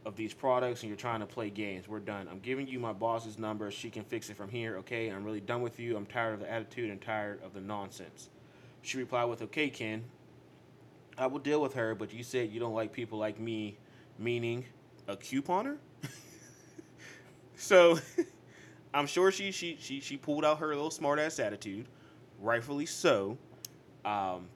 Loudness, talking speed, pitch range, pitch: -34 LUFS, 190 wpm, 110-135 Hz, 115 Hz